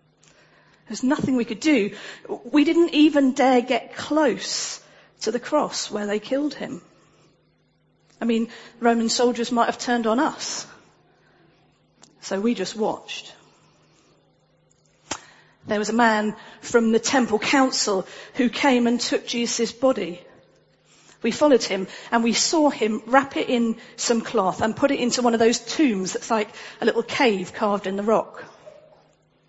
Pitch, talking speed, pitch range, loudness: 235 Hz, 150 wpm, 220-265 Hz, -22 LUFS